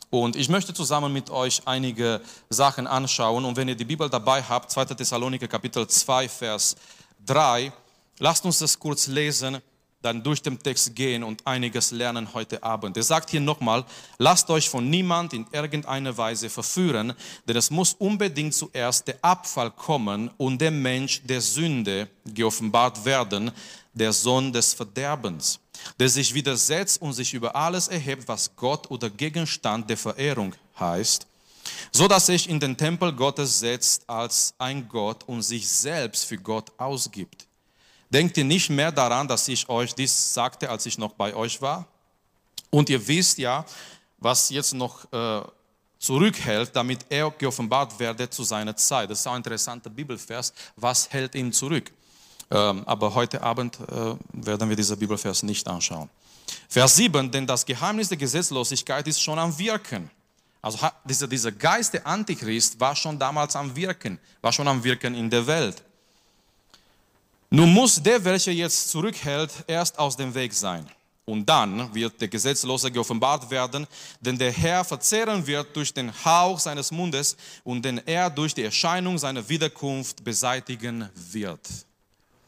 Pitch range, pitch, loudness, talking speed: 115-150 Hz, 130 Hz, -24 LUFS, 160 wpm